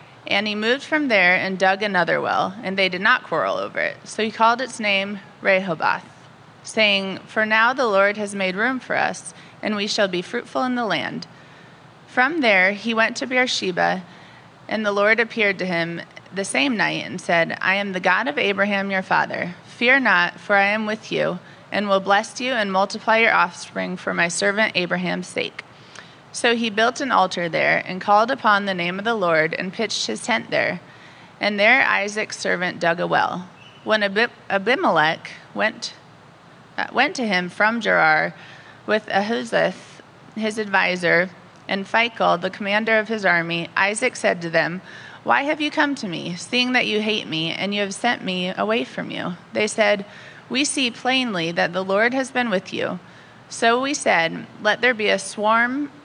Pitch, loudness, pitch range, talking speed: 205 Hz, -20 LUFS, 185-230 Hz, 185 wpm